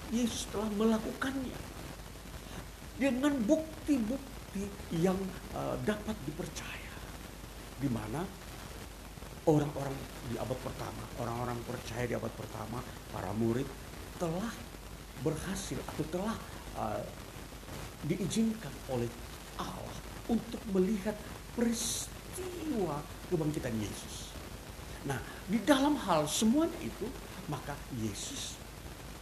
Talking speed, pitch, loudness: 85 wpm, 150 Hz, -36 LUFS